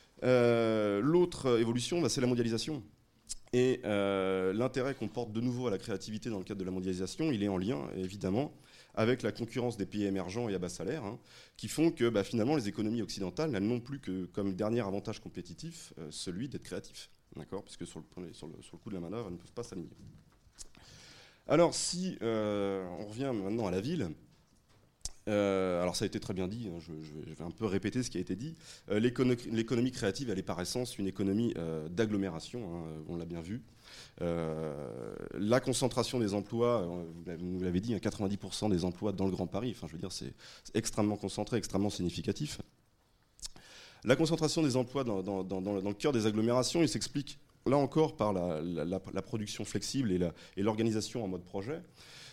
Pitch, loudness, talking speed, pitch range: 105 Hz, -34 LUFS, 205 wpm, 95-125 Hz